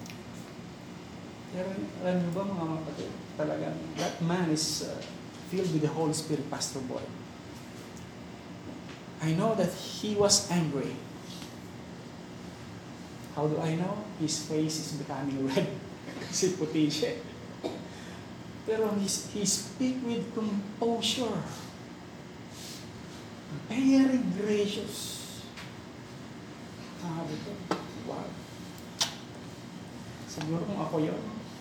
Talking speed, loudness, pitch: 95 wpm, -32 LUFS, 155 Hz